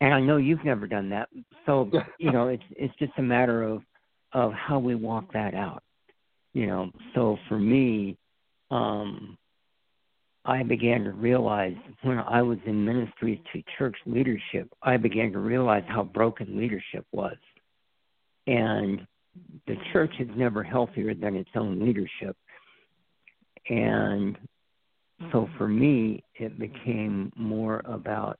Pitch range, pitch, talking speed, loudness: 105-130 Hz, 115 Hz, 140 wpm, -27 LUFS